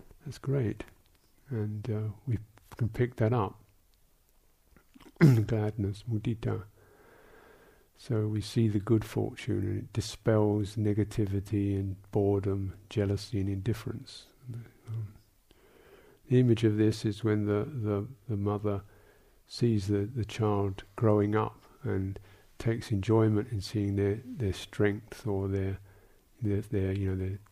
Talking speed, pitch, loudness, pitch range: 125 wpm, 105 Hz, -31 LUFS, 100-115 Hz